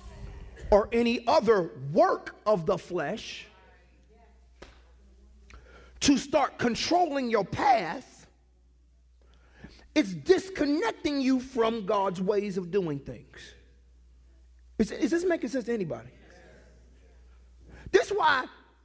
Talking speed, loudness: 100 wpm, -27 LUFS